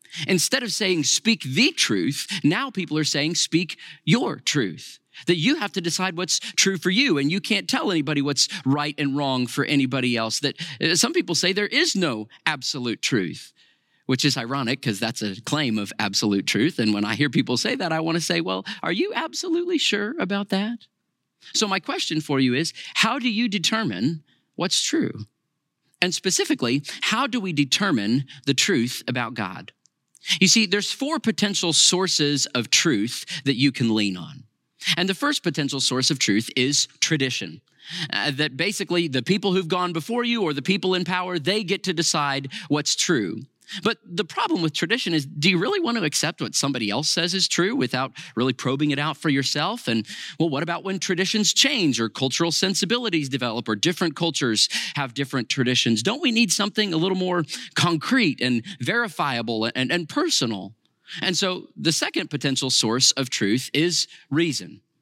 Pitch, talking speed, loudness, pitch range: 160 Hz, 185 wpm, -22 LUFS, 135-195 Hz